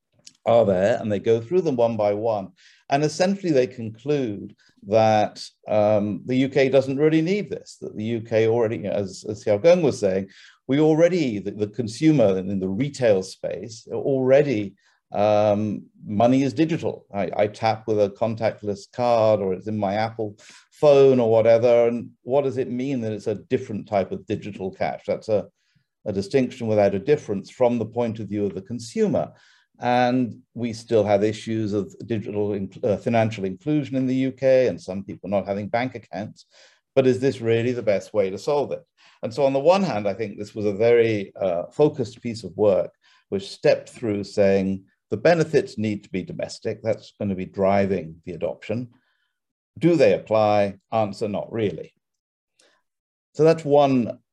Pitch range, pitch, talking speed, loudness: 105-130 Hz, 115 Hz, 180 wpm, -22 LUFS